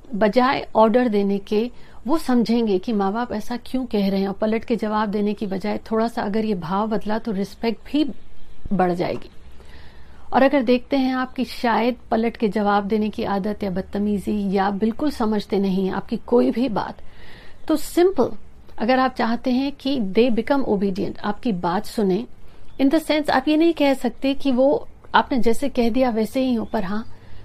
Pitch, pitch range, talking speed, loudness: 225 Hz, 205-255 Hz, 185 wpm, -21 LUFS